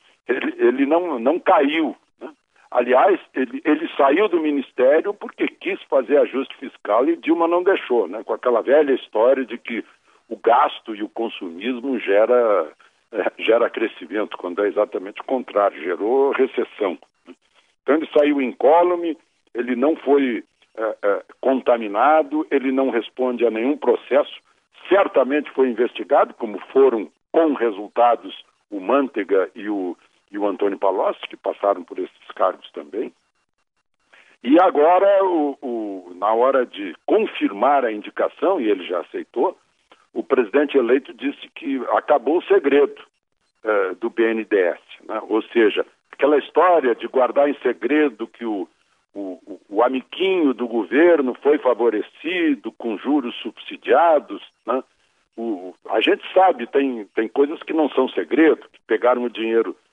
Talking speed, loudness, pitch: 145 wpm, -20 LUFS, 185 Hz